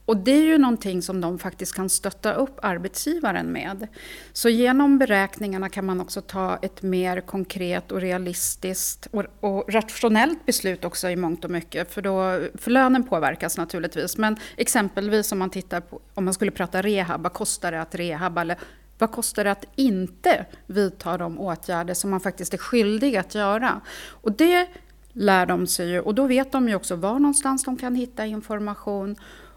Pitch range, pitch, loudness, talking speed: 185-230 Hz, 195 Hz, -23 LUFS, 180 wpm